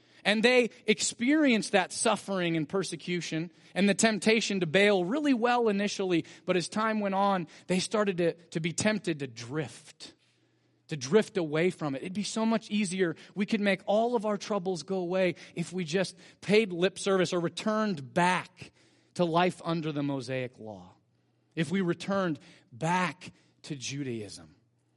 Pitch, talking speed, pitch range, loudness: 185 Hz, 165 wpm, 165-205 Hz, -29 LUFS